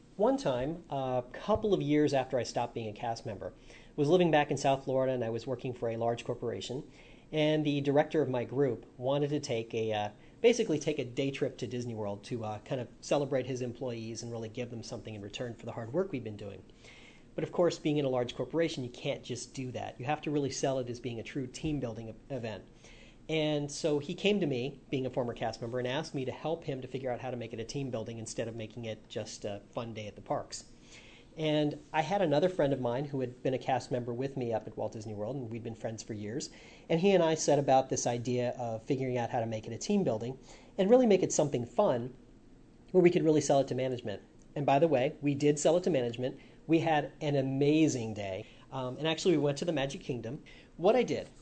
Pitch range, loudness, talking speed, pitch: 115-150 Hz, -32 LUFS, 255 wpm, 130 Hz